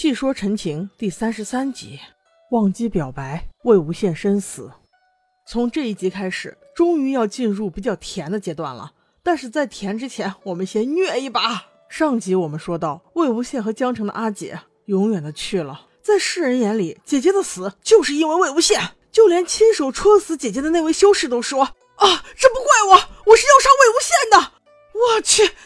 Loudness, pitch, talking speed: -18 LUFS, 250 Hz, 265 characters per minute